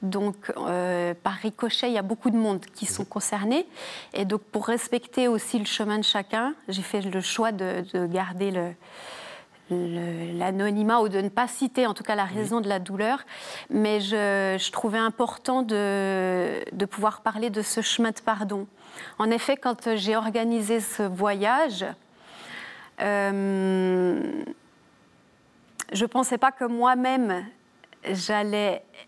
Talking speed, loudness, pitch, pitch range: 155 wpm, -26 LUFS, 210 Hz, 195-235 Hz